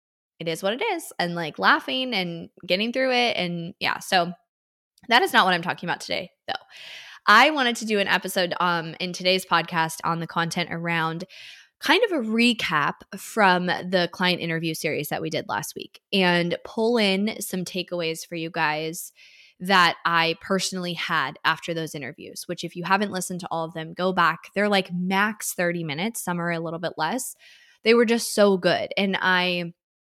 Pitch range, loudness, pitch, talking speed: 170-205 Hz, -23 LUFS, 180 Hz, 190 wpm